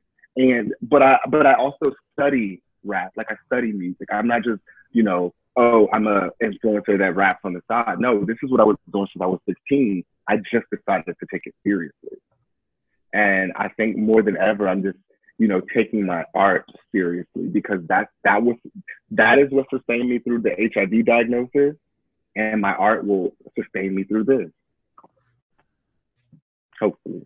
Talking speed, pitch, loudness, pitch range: 175 wpm, 110 Hz, -20 LUFS, 100-120 Hz